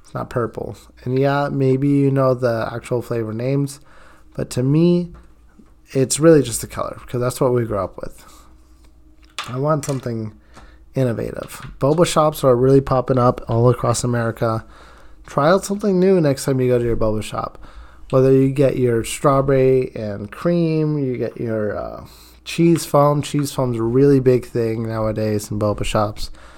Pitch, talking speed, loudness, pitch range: 125 Hz, 165 wpm, -18 LUFS, 110-140 Hz